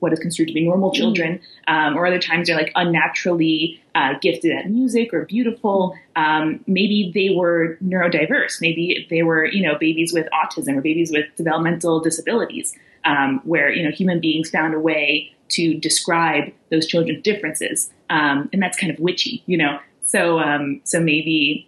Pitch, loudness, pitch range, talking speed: 165 Hz, -19 LUFS, 160-180 Hz, 175 wpm